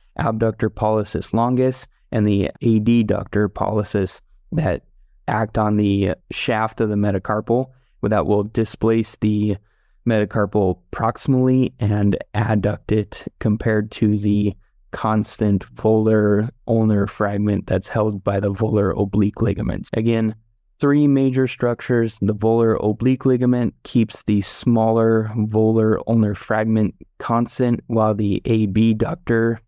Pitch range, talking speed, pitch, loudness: 105-115 Hz, 115 wpm, 110 Hz, -20 LUFS